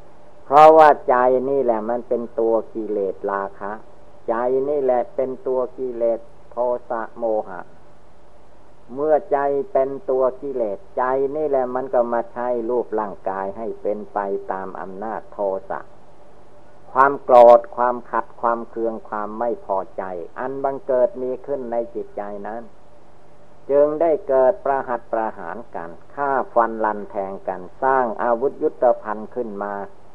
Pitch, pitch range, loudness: 120 Hz, 110-135 Hz, -20 LUFS